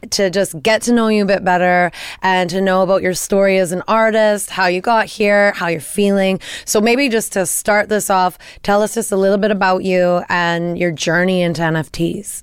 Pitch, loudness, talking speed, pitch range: 190 Hz, -15 LUFS, 215 wpm, 180-210 Hz